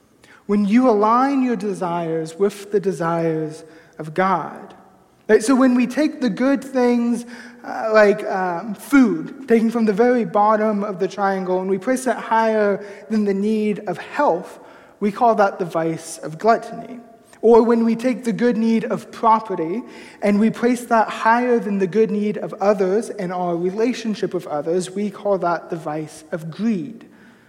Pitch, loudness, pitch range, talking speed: 215 Hz, -19 LUFS, 190-235 Hz, 170 wpm